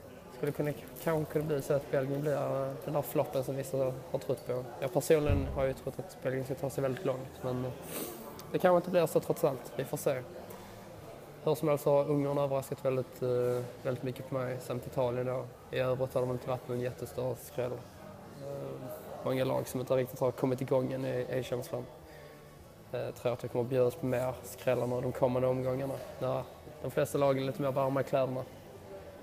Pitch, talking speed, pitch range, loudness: 130 Hz, 205 wpm, 125-140 Hz, -33 LUFS